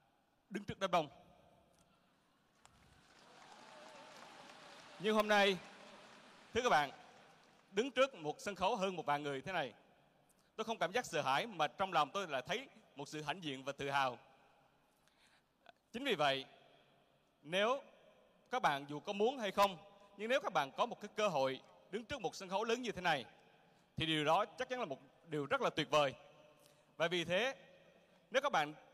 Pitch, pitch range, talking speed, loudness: 180 Hz, 150-205 Hz, 180 wpm, -38 LUFS